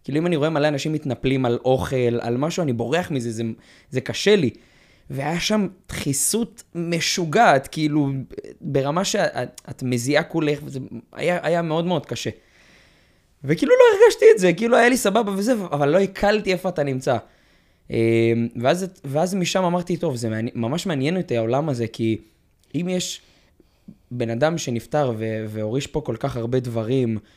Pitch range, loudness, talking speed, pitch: 120-180 Hz, -21 LUFS, 160 wpm, 145 Hz